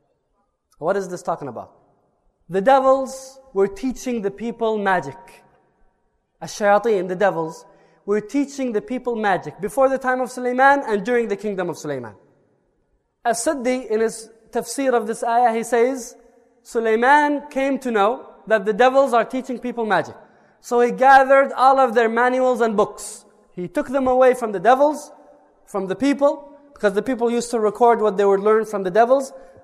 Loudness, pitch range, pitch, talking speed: -19 LUFS, 210-260 Hz, 235 Hz, 170 wpm